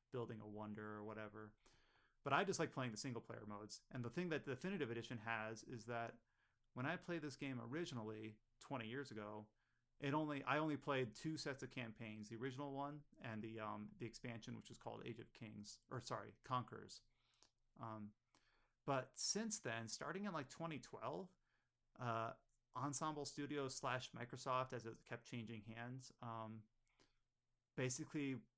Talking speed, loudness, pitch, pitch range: 165 wpm, -49 LUFS, 120 Hz, 115-140 Hz